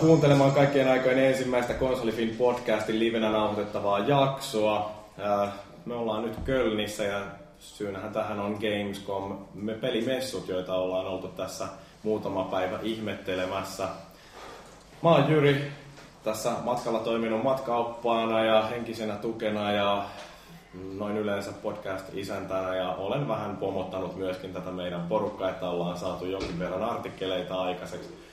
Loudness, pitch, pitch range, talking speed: -28 LUFS, 105 Hz, 95-115 Hz, 120 wpm